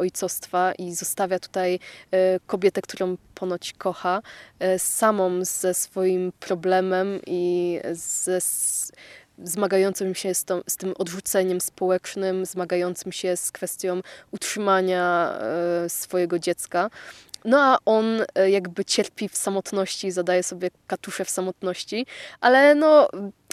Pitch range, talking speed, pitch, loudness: 180-195 Hz, 120 wpm, 185 Hz, -23 LUFS